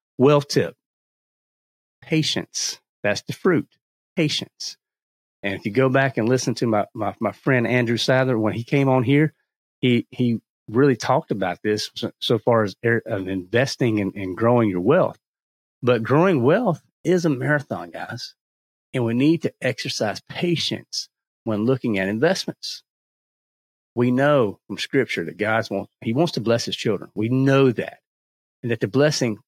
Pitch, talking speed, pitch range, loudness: 120 Hz, 155 wpm, 105-135 Hz, -22 LUFS